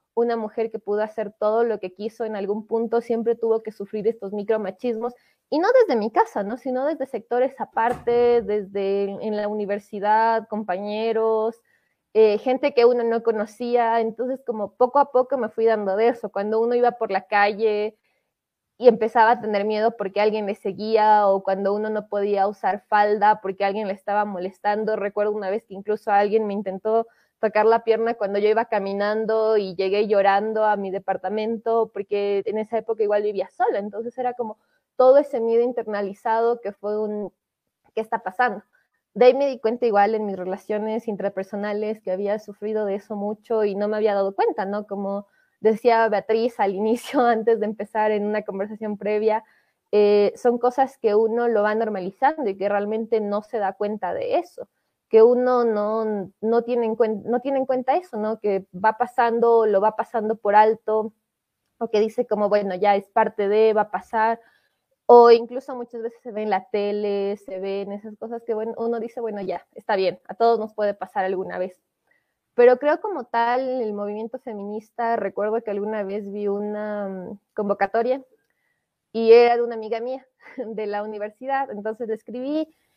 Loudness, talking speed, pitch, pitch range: -22 LUFS, 185 wpm, 220 Hz, 205-230 Hz